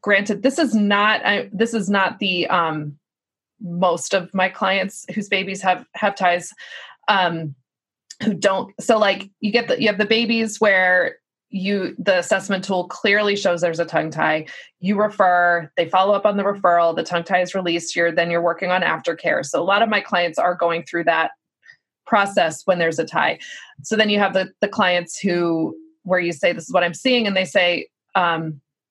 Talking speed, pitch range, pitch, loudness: 200 wpm, 175-210 Hz, 190 Hz, -19 LUFS